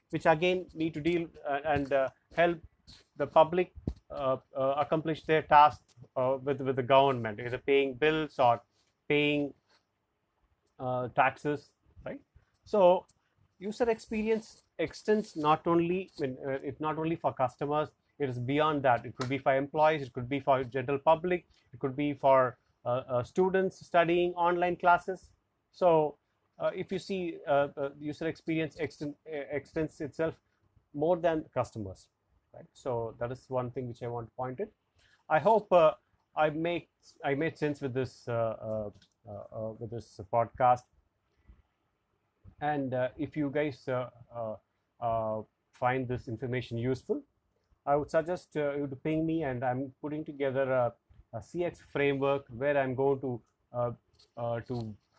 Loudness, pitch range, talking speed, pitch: -31 LUFS, 120-155 Hz, 155 wpm, 140 Hz